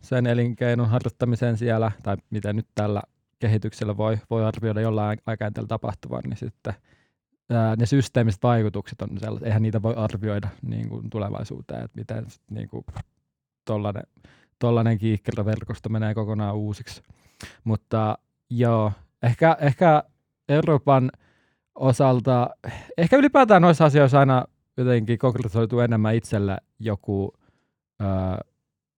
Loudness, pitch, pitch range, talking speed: -23 LUFS, 115 Hz, 105-125 Hz, 120 wpm